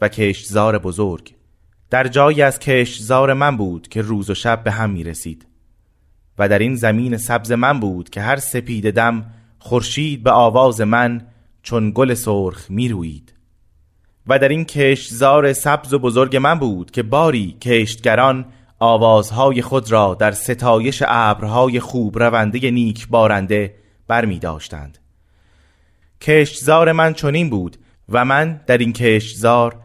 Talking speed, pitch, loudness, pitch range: 145 wpm, 115 Hz, -16 LUFS, 105-130 Hz